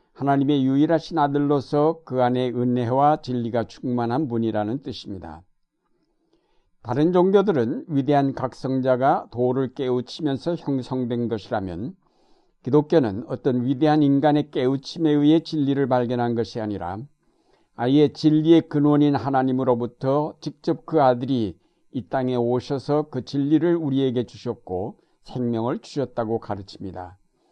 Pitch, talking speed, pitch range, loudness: 135 Hz, 300 characters per minute, 120-150 Hz, -22 LUFS